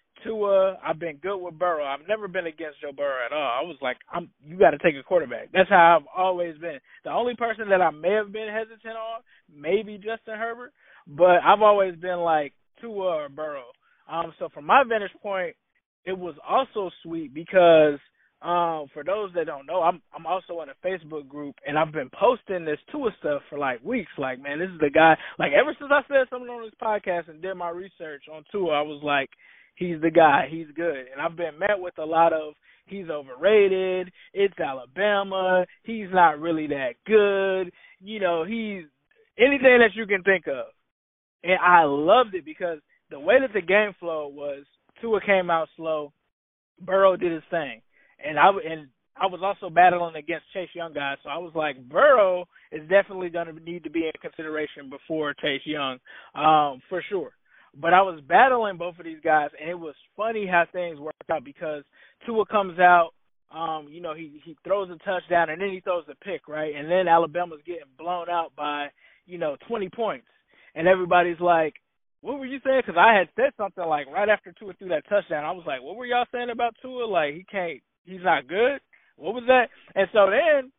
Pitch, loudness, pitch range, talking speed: 180 Hz, -23 LUFS, 160-205 Hz, 205 wpm